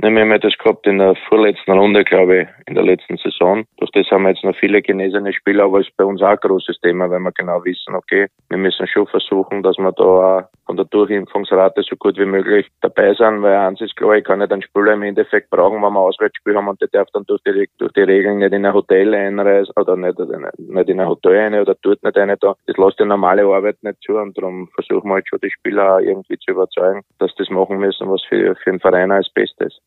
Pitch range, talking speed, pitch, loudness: 95-110 Hz, 255 wpm, 100 Hz, -15 LUFS